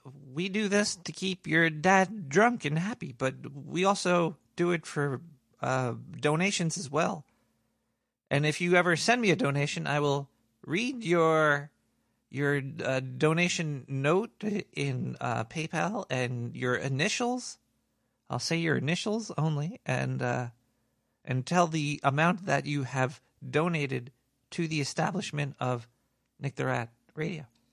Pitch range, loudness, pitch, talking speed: 135-175 Hz, -29 LUFS, 150 Hz, 140 wpm